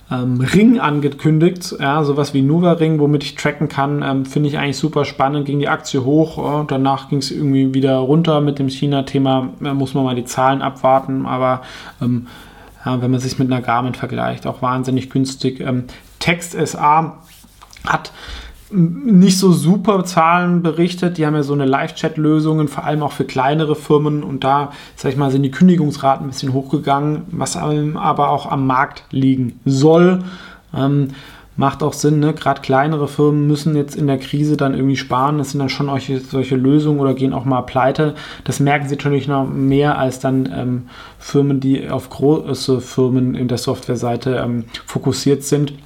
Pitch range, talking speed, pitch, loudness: 135-150 Hz, 180 wpm, 140 Hz, -16 LUFS